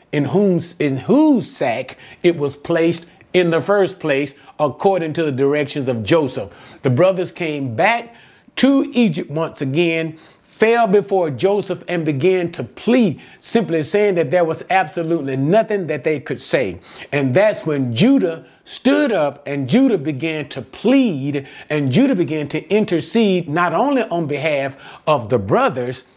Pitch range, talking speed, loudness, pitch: 145-195 Hz, 155 wpm, -18 LUFS, 165 Hz